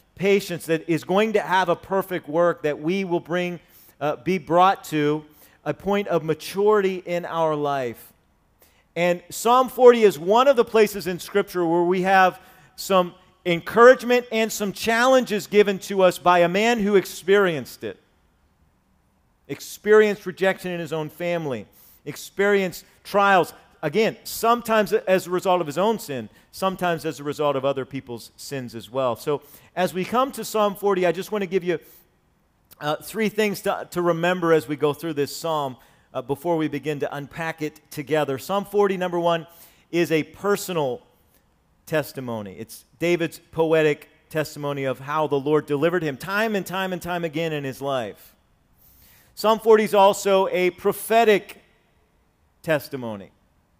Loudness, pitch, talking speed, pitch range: -22 LUFS, 170 Hz, 160 wpm, 145-195 Hz